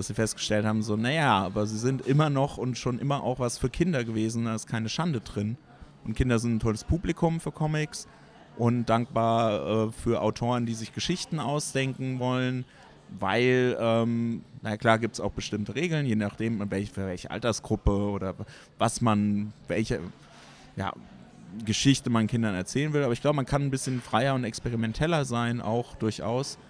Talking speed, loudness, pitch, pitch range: 180 wpm, -28 LUFS, 115 Hz, 110-130 Hz